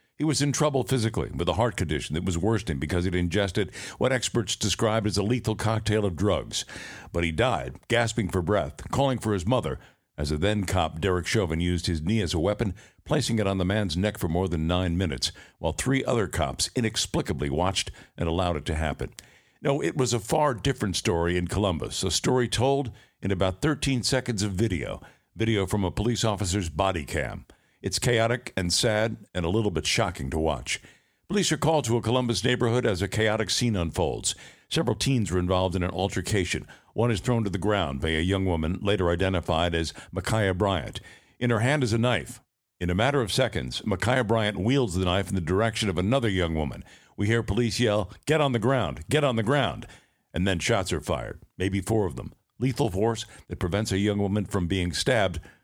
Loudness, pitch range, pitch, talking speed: -26 LUFS, 90-115 Hz, 105 Hz, 205 wpm